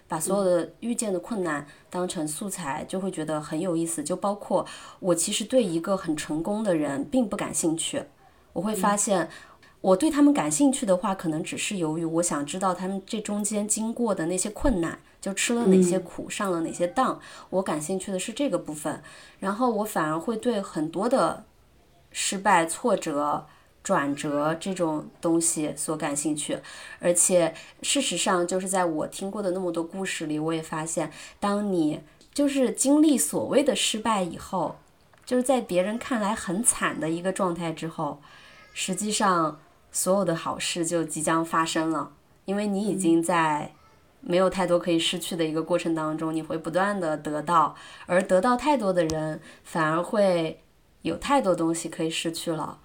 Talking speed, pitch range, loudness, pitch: 265 characters per minute, 165-205 Hz, -26 LUFS, 180 Hz